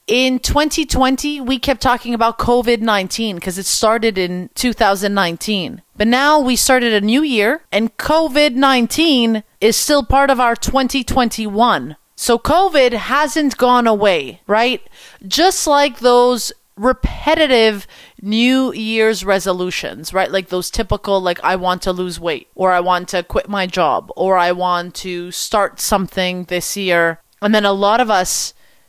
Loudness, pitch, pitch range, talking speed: -15 LUFS, 225 Hz, 190-260 Hz, 145 wpm